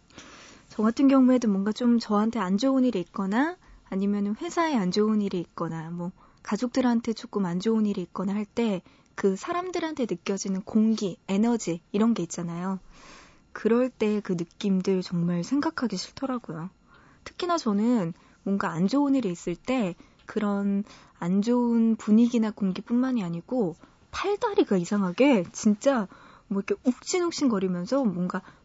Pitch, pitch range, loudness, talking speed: 210 Hz, 190-245 Hz, -26 LUFS, 310 characters per minute